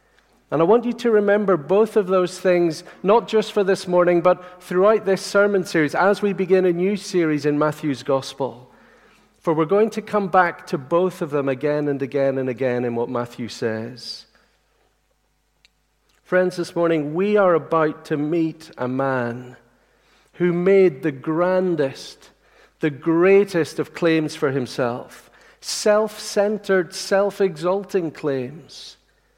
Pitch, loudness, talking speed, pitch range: 175 Hz, -20 LUFS, 150 wpm, 150-195 Hz